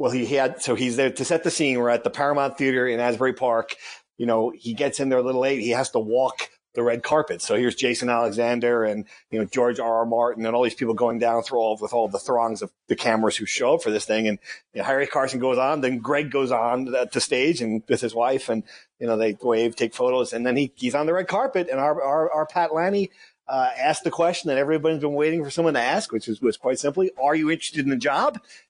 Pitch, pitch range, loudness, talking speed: 130 Hz, 115-145 Hz, -23 LUFS, 270 wpm